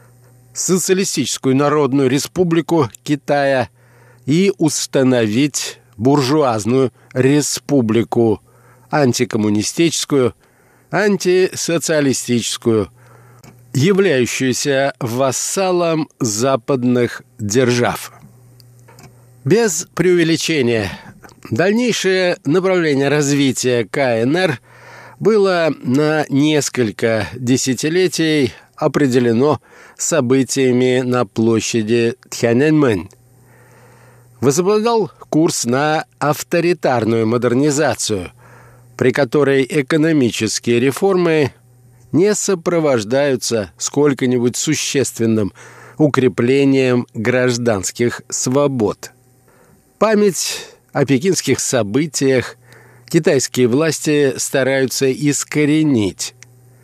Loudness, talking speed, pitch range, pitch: -16 LUFS, 55 wpm, 120-150 Hz, 130 Hz